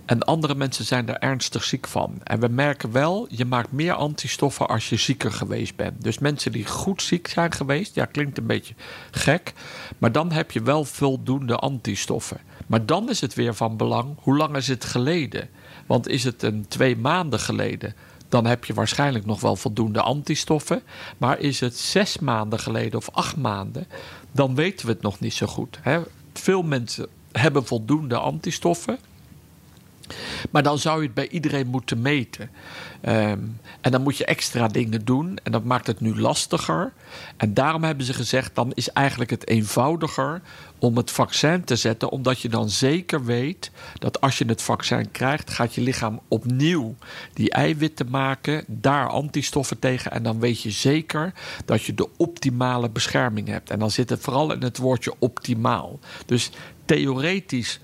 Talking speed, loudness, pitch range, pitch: 175 wpm, -23 LUFS, 115-145 Hz, 130 Hz